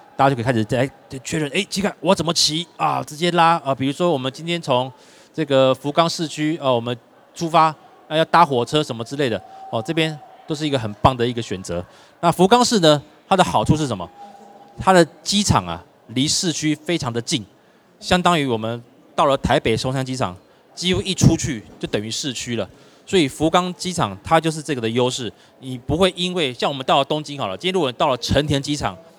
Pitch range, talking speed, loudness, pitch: 130-170 Hz, 315 characters per minute, -20 LUFS, 150 Hz